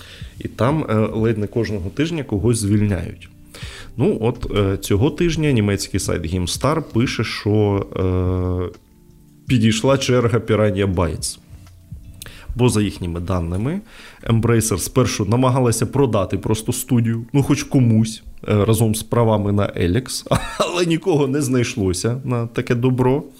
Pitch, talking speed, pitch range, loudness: 110 Hz, 130 wpm, 100-125 Hz, -19 LUFS